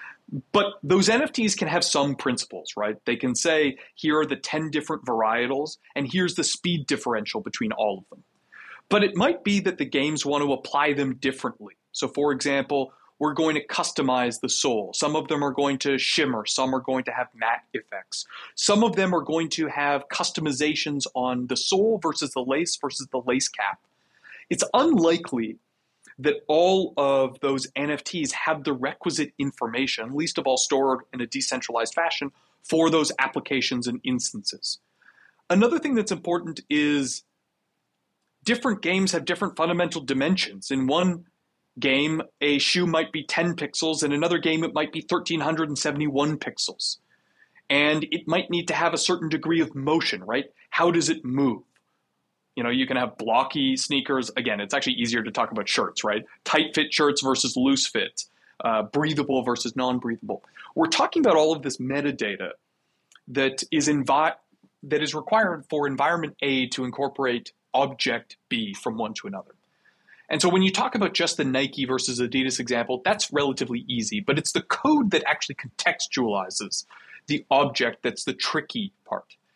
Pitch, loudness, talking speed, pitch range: 150 Hz, -24 LUFS, 170 wpm, 135-170 Hz